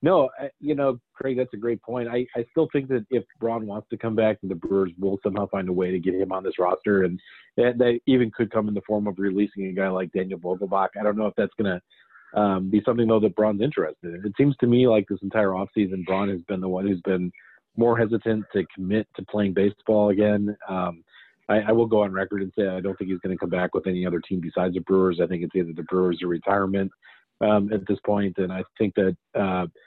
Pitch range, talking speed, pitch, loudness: 95-110 Hz, 255 wpm, 100 Hz, -24 LUFS